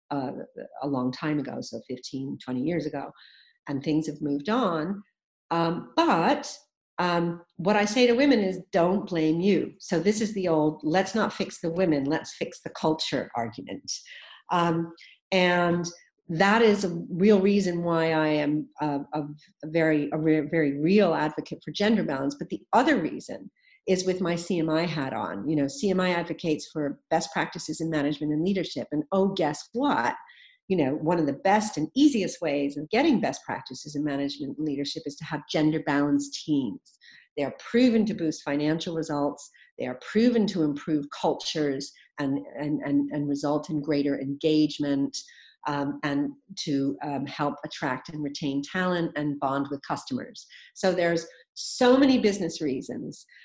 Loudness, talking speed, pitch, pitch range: -27 LUFS, 170 wpm, 160 Hz, 145-195 Hz